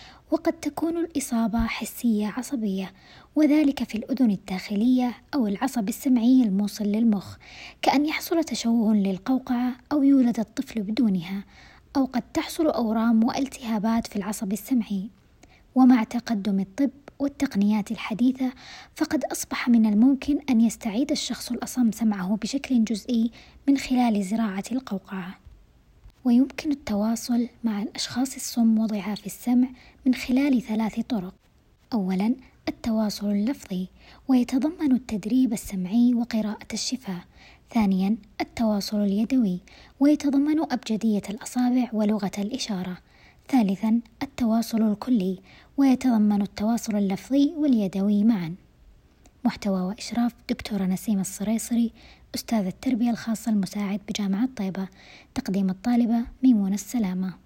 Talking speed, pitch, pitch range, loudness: 105 wpm, 230 Hz, 210-255 Hz, -25 LUFS